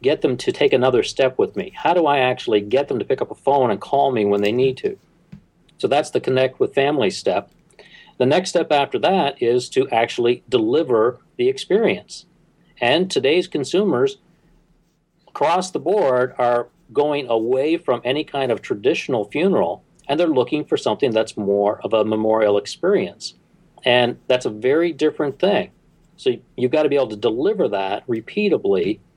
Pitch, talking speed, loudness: 145 Hz, 175 wpm, -19 LUFS